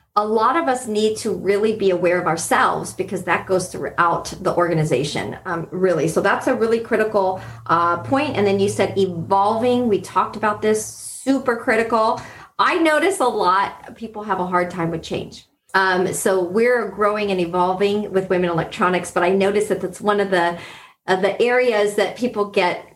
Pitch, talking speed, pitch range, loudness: 195 Hz, 185 wpm, 180-220 Hz, -19 LUFS